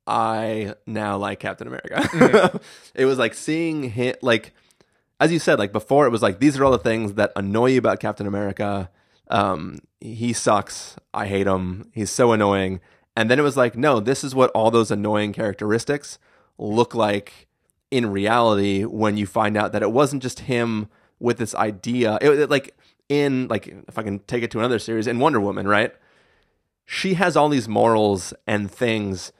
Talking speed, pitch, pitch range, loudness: 190 wpm, 110 Hz, 105-125 Hz, -21 LUFS